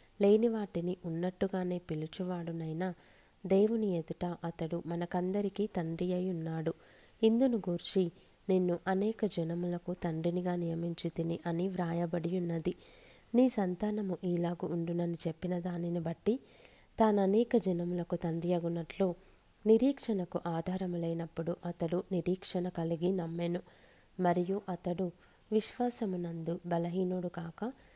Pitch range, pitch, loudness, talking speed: 170-195 Hz, 180 Hz, -34 LUFS, 100 wpm